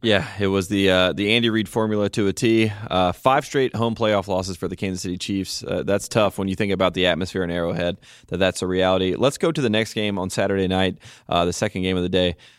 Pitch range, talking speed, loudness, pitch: 90-110 Hz, 255 wpm, -21 LUFS, 95 Hz